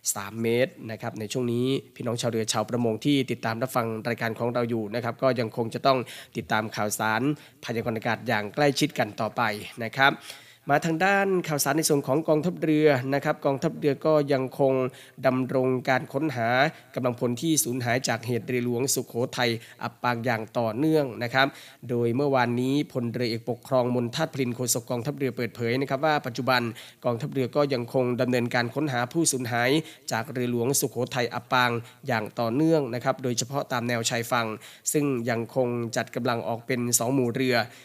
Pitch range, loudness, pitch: 120-135 Hz, -26 LUFS, 125 Hz